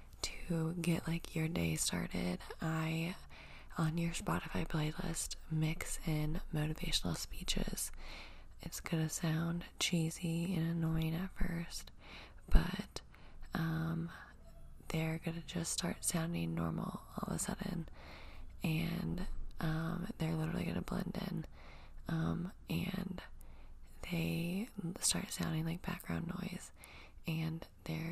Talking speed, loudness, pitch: 110 wpm, -39 LUFS, 160 Hz